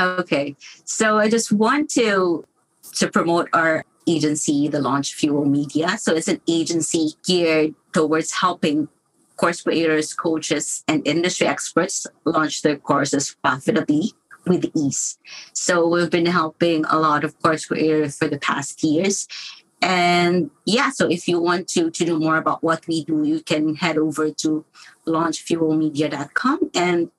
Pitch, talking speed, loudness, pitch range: 160 Hz, 150 wpm, -20 LUFS, 155-175 Hz